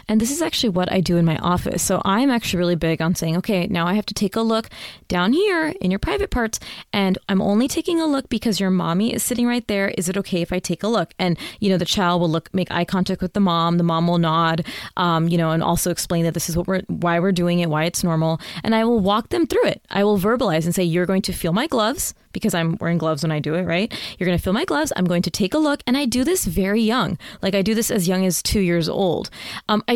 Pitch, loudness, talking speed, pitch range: 185 Hz, -20 LUFS, 290 wpm, 175-220 Hz